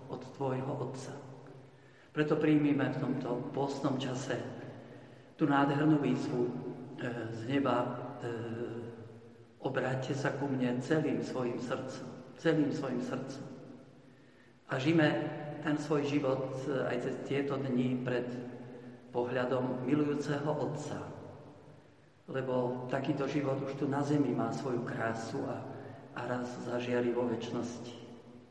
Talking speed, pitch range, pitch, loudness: 115 wpm, 125-140 Hz, 130 Hz, -34 LUFS